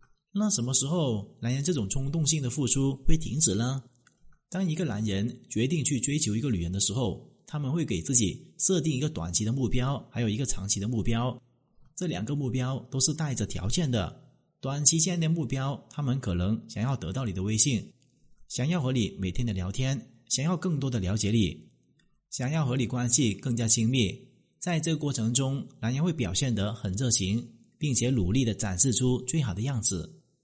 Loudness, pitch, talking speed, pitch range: -27 LUFS, 125 Hz, 285 characters per minute, 110-145 Hz